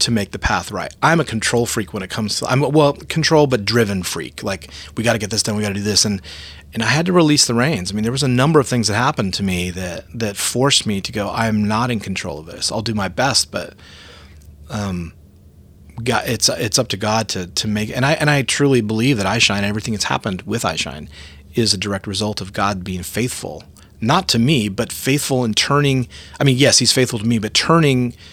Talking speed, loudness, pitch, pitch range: 250 wpm, -17 LUFS, 110 Hz, 95-125 Hz